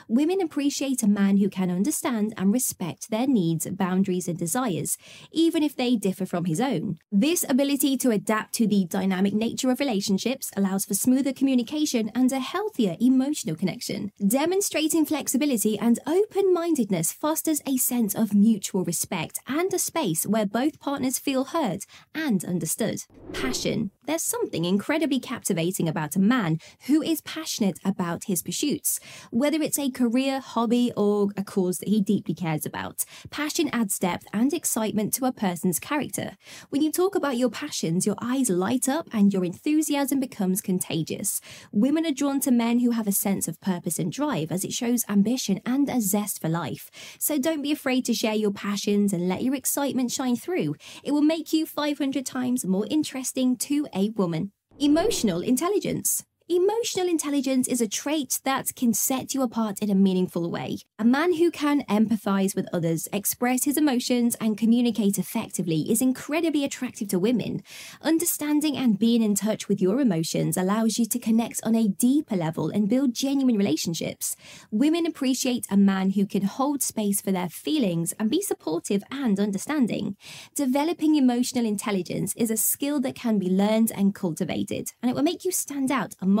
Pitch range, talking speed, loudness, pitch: 200-280 Hz, 175 wpm, -25 LUFS, 235 Hz